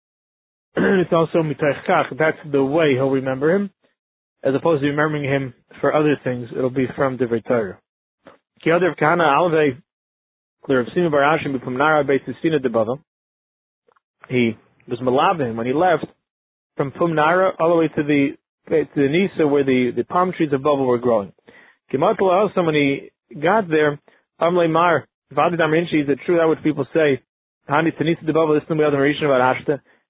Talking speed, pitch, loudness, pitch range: 140 wpm, 150 Hz, -19 LUFS, 135-165 Hz